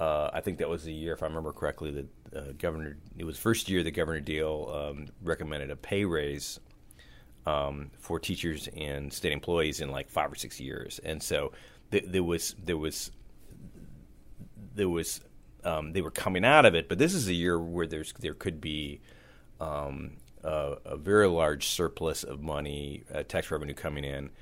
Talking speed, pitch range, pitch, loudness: 190 wpm, 70-85 Hz, 75 Hz, -31 LUFS